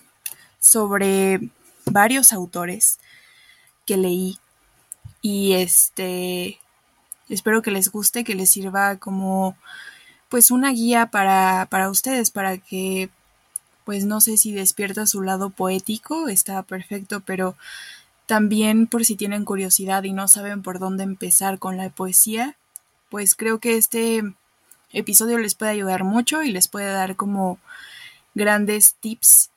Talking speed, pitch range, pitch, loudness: 130 wpm, 190-220 Hz, 200 Hz, -18 LUFS